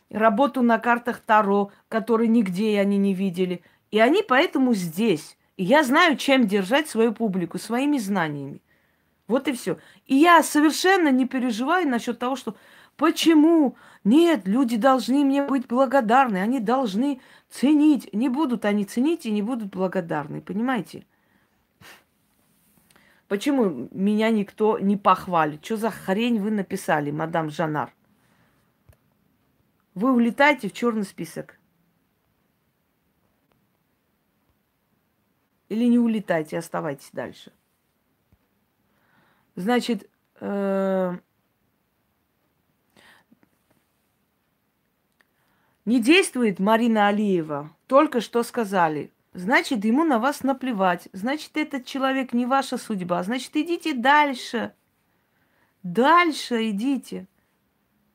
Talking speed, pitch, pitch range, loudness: 100 wpm, 230 Hz, 195-270 Hz, -22 LUFS